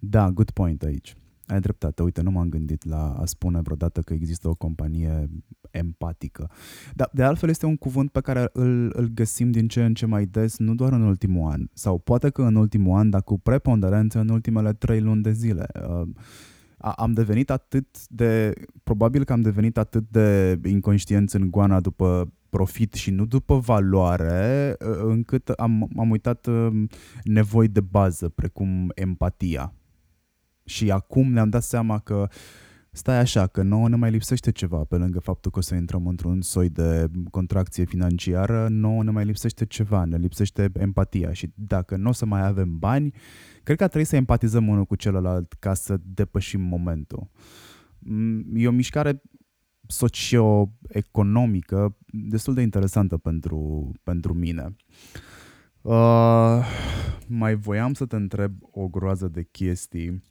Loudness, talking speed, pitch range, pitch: -23 LUFS, 160 wpm, 90-115 Hz, 100 Hz